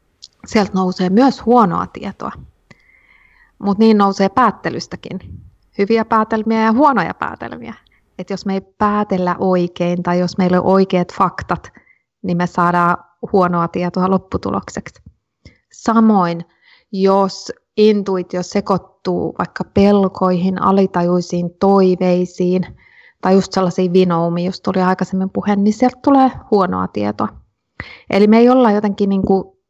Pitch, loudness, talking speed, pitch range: 190 Hz, -15 LUFS, 120 wpm, 180-210 Hz